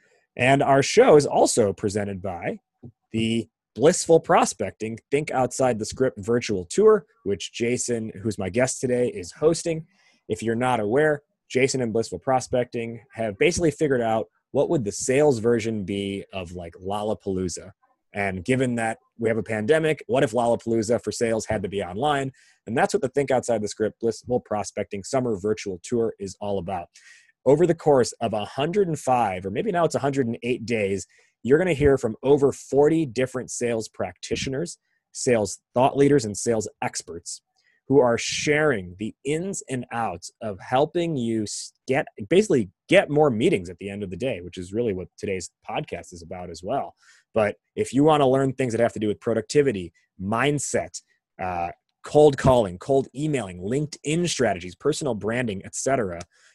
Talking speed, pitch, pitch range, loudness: 170 wpm, 120 Hz, 105-145 Hz, -24 LUFS